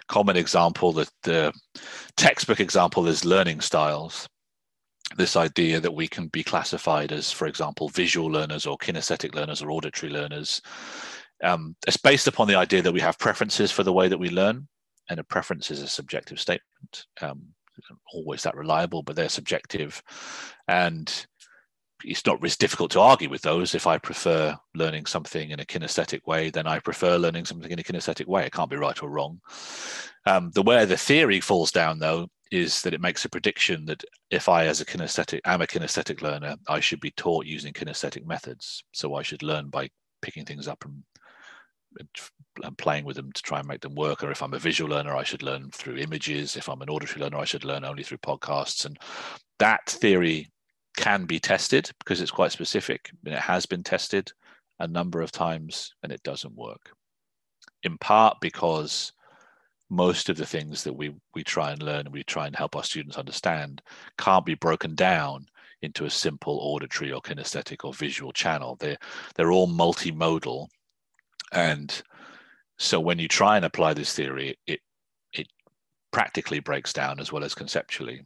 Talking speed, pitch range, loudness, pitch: 185 wpm, 75-85 Hz, -25 LUFS, 80 Hz